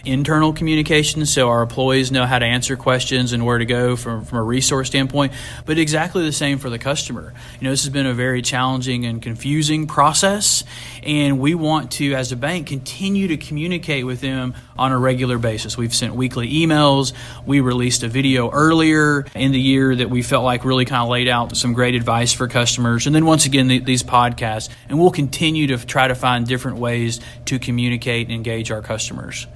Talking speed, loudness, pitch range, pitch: 205 wpm, -18 LUFS, 120-145 Hz, 130 Hz